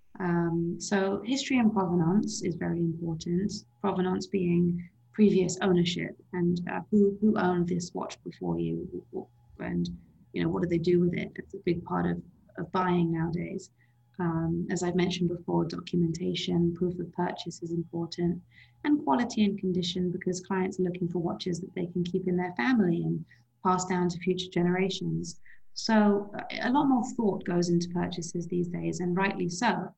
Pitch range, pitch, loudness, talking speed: 170-190 Hz, 180 Hz, -29 LUFS, 170 wpm